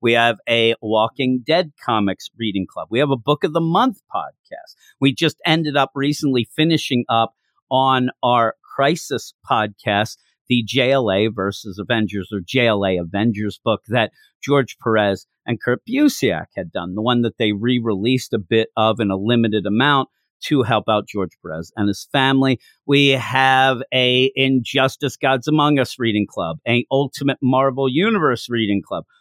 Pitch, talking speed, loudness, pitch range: 125 Hz, 160 wpm, -19 LUFS, 110-135 Hz